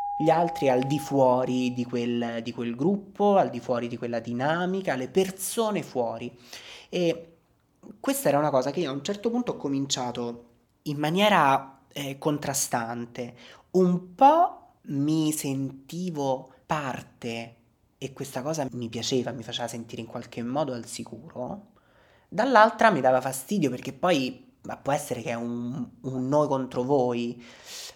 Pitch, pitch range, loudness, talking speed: 135 Hz, 120-165 Hz, -26 LUFS, 150 wpm